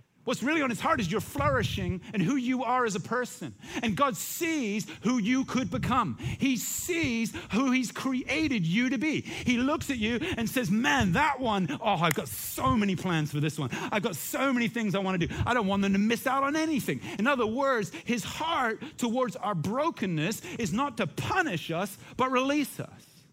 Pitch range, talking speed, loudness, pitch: 200-265 Hz, 210 wpm, -29 LUFS, 235 Hz